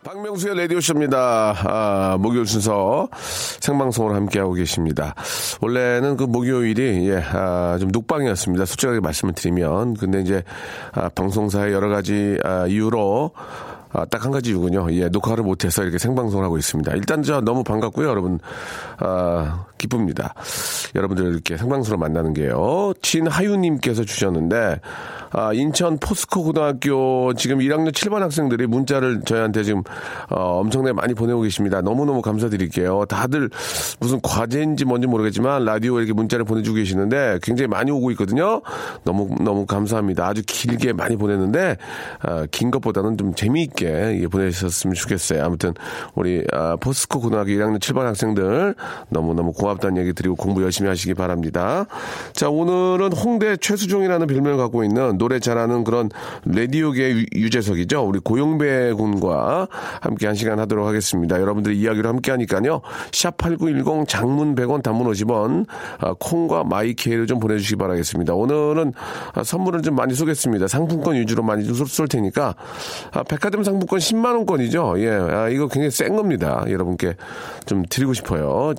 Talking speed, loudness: 370 characters per minute, -20 LUFS